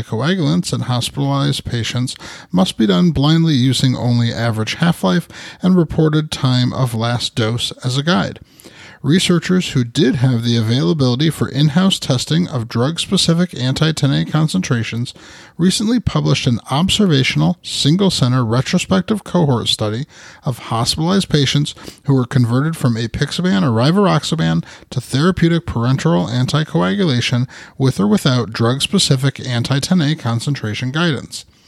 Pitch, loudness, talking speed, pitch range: 140 Hz, -16 LUFS, 135 wpm, 125-170 Hz